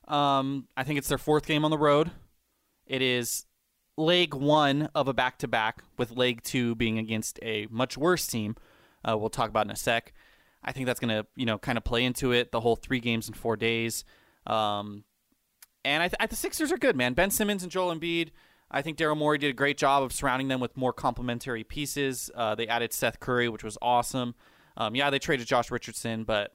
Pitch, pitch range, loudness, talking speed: 125 Hz, 115-145 Hz, -28 LUFS, 220 wpm